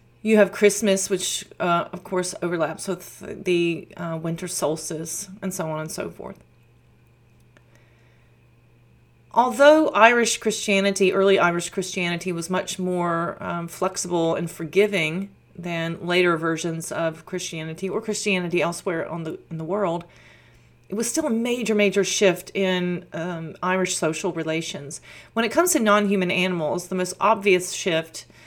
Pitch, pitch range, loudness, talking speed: 180 Hz, 160-195 Hz, -23 LUFS, 140 wpm